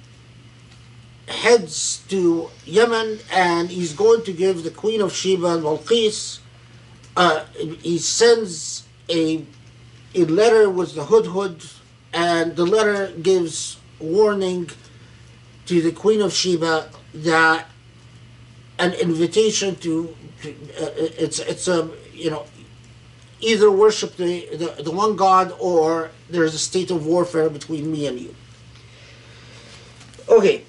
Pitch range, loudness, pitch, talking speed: 120-185 Hz, -19 LUFS, 160 Hz, 120 wpm